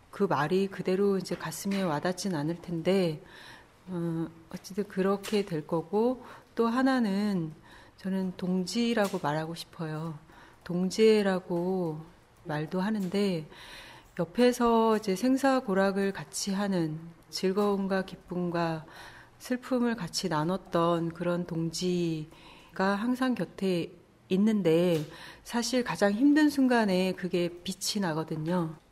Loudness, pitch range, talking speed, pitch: -29 LUFS, 170-205 Hz, 230 characters per minute, 185 Hz